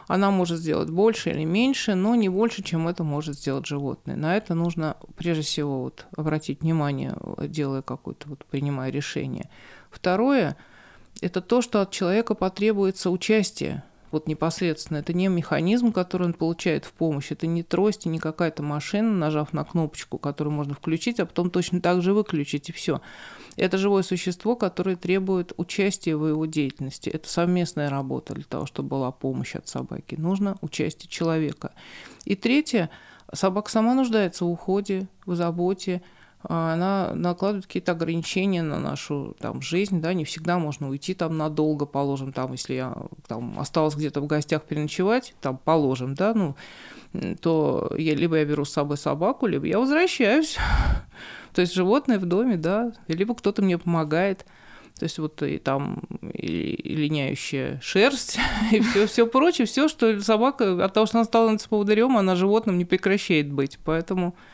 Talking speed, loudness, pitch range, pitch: 160 wpm, -25 LUFS, 155-200 Hz, 175 Hz